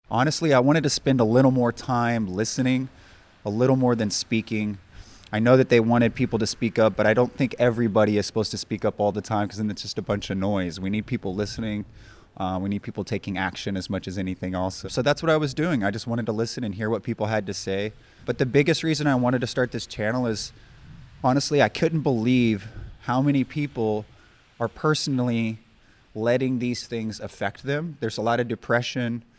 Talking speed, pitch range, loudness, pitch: 220 wpm, 105-125 Hz, -24 LUFS, 115 Hz